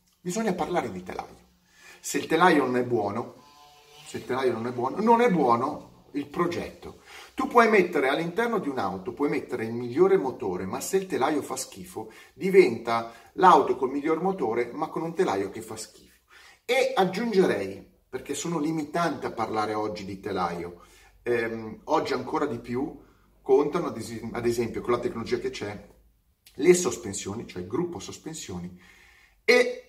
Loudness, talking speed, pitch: -26 LUFS, 165 wpm, 150 Hz